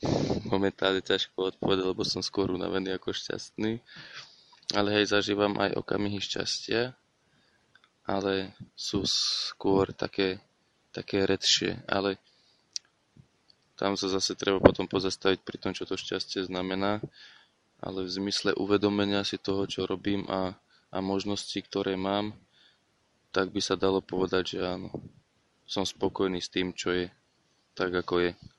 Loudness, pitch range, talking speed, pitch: -29 LUFS, 95-100 Hz, 130 wpm, 95 Hz